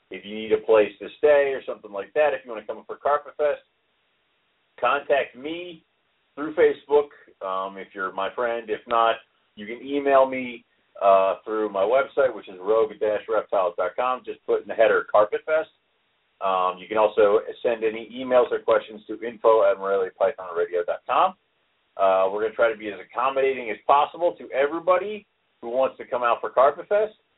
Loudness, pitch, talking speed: -23 LUFS, 145 Hz, 175 wpm